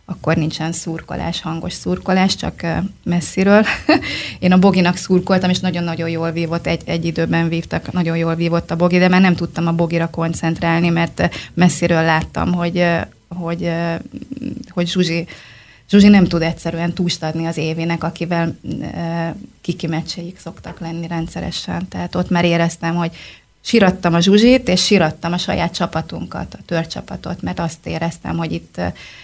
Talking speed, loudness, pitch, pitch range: 150 wpm, -17 LUFS, 170 Hz, 165-180 Hz